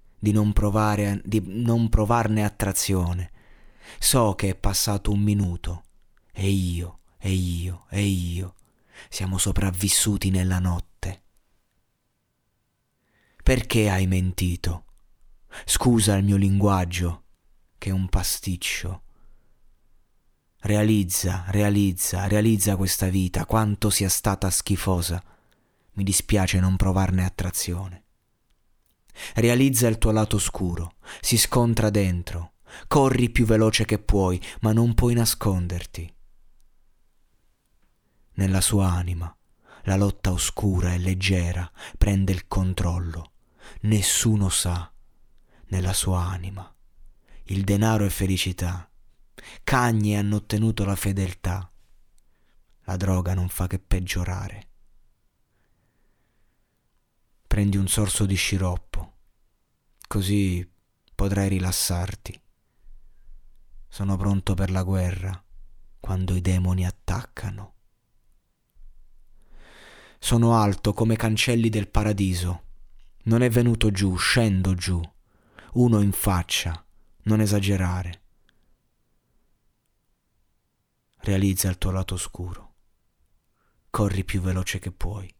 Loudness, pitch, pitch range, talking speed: -24 LUFS, 95 Hz, 90-105 Hz, 100 wpm